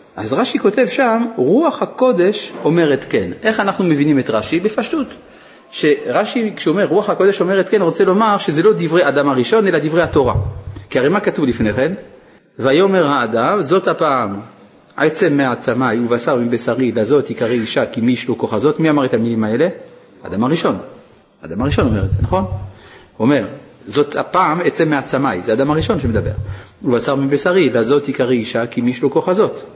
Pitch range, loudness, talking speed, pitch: 120-195 Hz, -16 LUFS, 175 wpm, 145 Hz